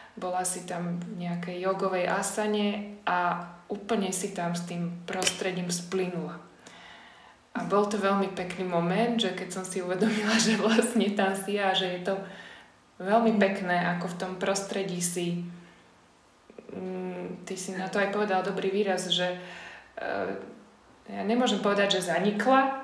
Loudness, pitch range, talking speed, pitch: -28 LUFS, 180-205 Hz, 145 wpm, 190 Hz